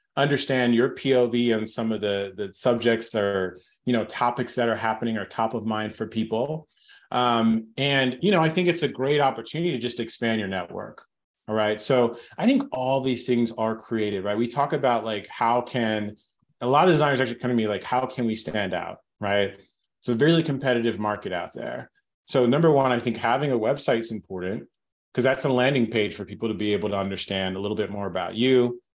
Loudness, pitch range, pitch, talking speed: -24 LUFS, 105-130 Hz, 115 Hz, 215 wpm